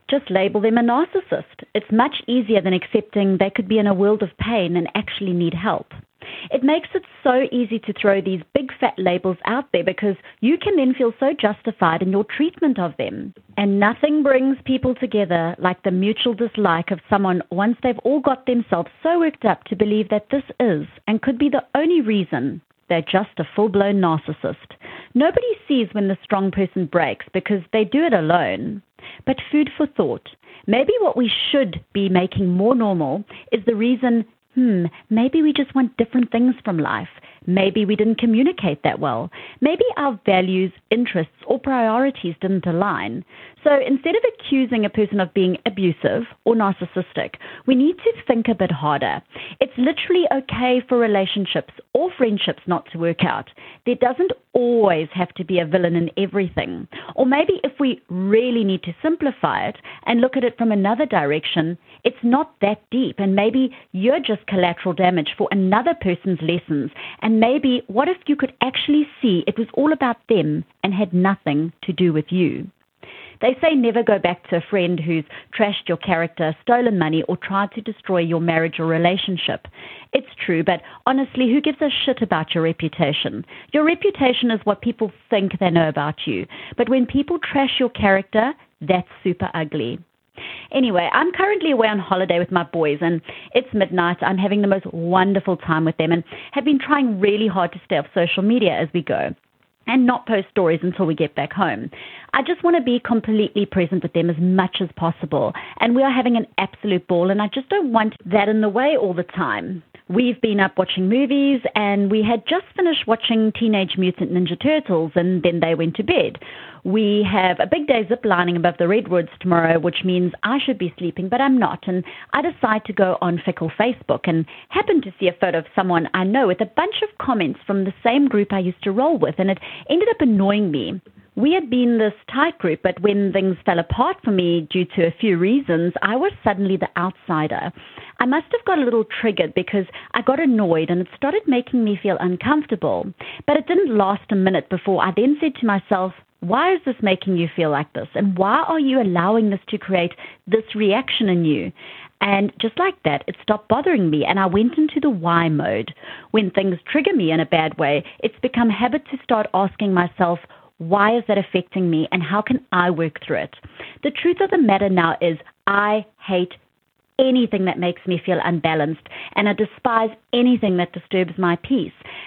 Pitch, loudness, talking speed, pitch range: 205 Hz, -19 LUFS, 200 wpm, 180-250 Hz